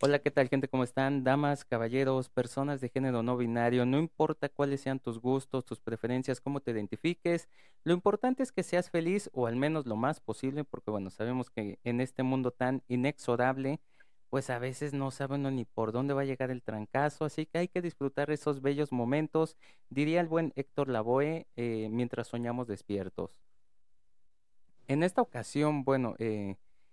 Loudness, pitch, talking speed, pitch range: -33 LUFS, 135 Hz, 180 wpm, 120-145 Hz